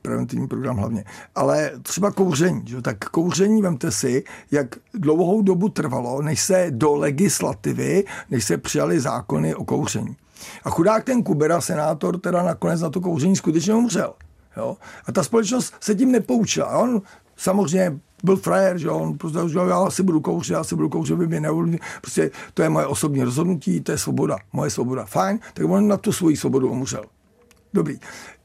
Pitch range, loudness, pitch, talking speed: 145-195 Hz, -21 LUFS, 175 Hz, 175 wpm